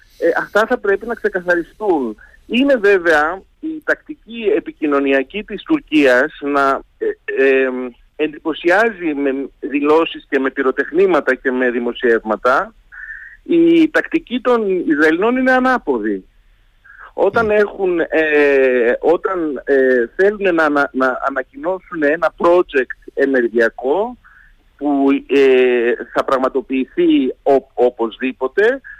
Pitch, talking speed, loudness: 155 Hz, 105 wpm, -16 LUFS